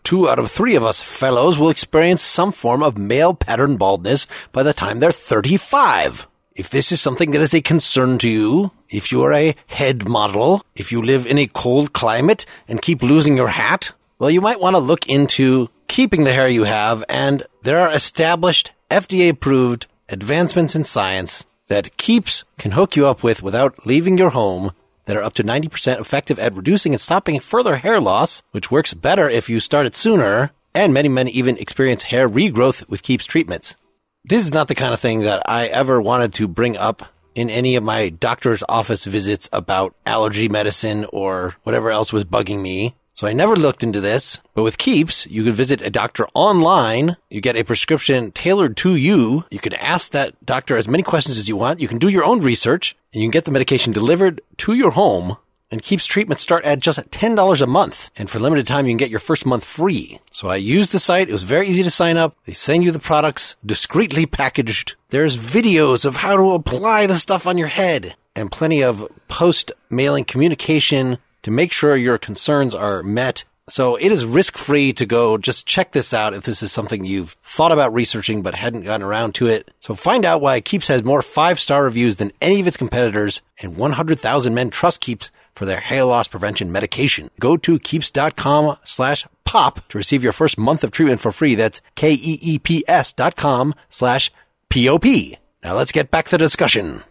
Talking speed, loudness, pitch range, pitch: 210 wpm, -17 LUFS, 110-160 Hz, 135 Hz